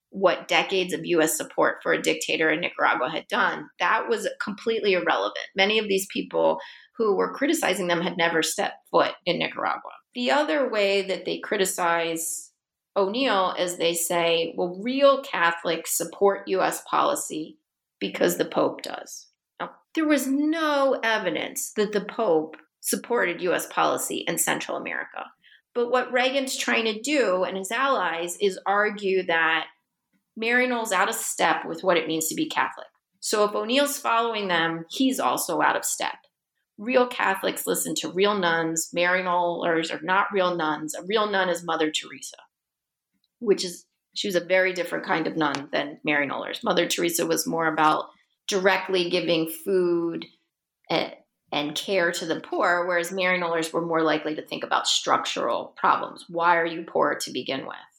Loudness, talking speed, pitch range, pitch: -24 LUFS, 160 wpm, 170-230 Hz, 185 Hz